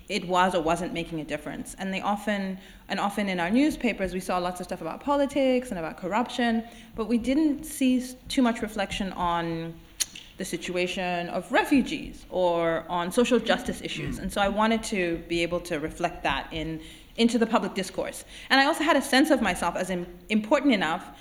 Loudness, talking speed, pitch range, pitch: -26 LUFS, 190 wpm, 175-245 Hz, 195 Hz